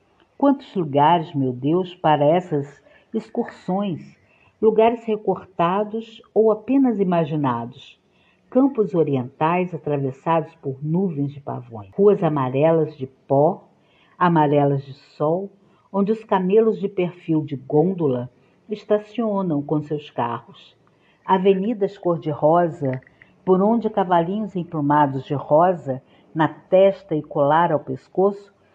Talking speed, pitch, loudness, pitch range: 105 wpm, 170 Hz, -21 LUFS, 145-200 Hz